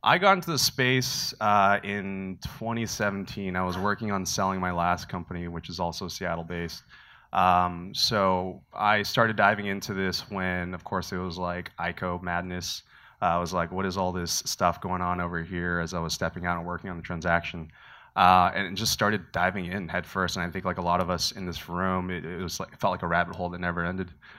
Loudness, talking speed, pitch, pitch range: -27 LUFS, 225 wpm, 90 Hz, 85-95 Hz